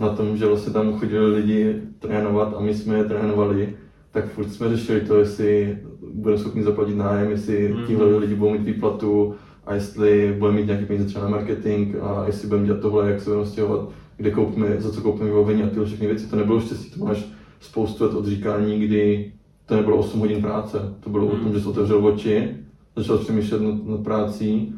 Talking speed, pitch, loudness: 205 wpm, 105 Hz, -22 LUFS